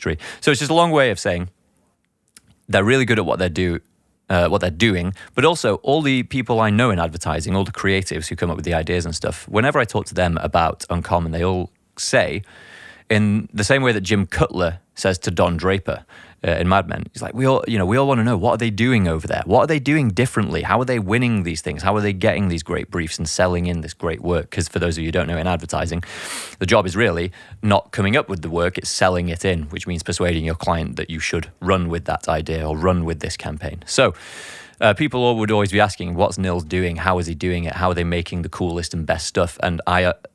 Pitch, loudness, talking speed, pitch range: 90 Hz, -20 LUFS, 260 wpm, 85-105 Hz